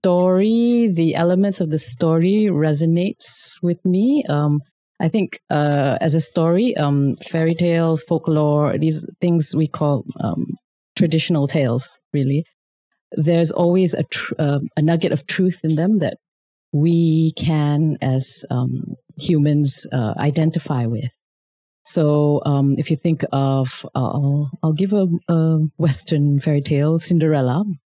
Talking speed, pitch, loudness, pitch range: 135 wpm, 160 Hz, -19 LUFS, 145-175 Hz